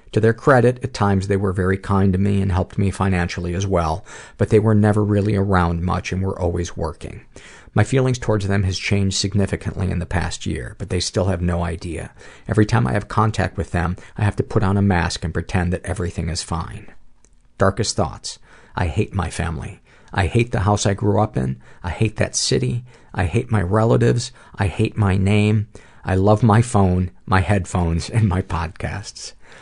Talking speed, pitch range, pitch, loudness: 205 wpm, 90-105 Hz, 100 Hz, -20 LUFS